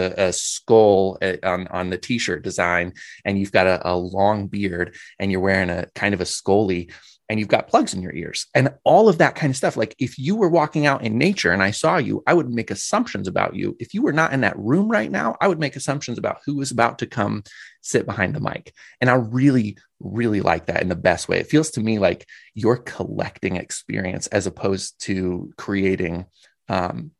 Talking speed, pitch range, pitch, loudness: 225 wpm, 95-135 Hz, 105 Hz, -21 LUFS